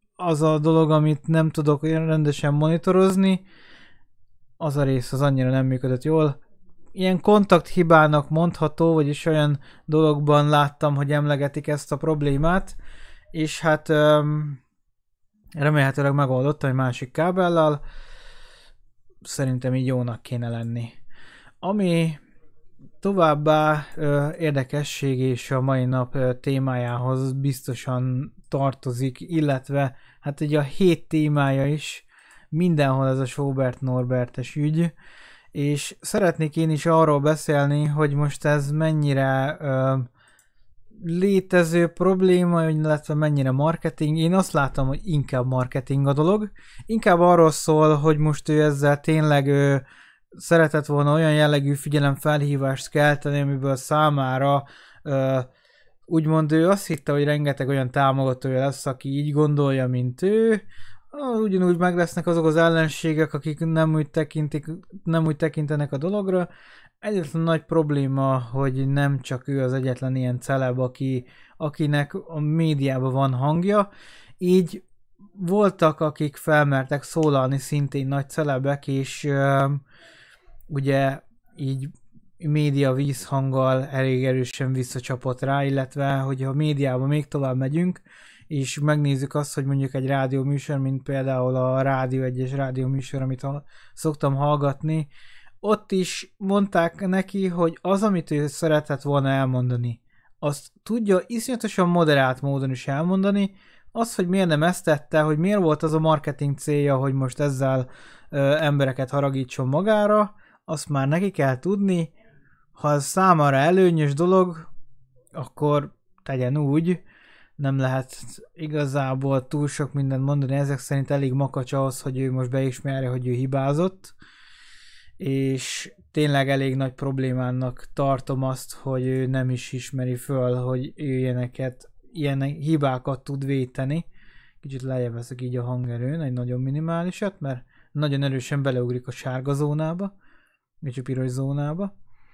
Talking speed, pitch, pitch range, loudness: 130 wpm, 145 Hz, 135-160 Hz, -23 LUFS